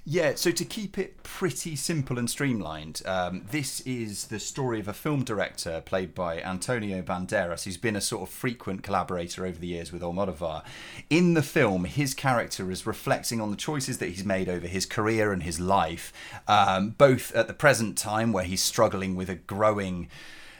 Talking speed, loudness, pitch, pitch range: 190 wpm, -28 LUFS, 100 Hz, 95-130 Hz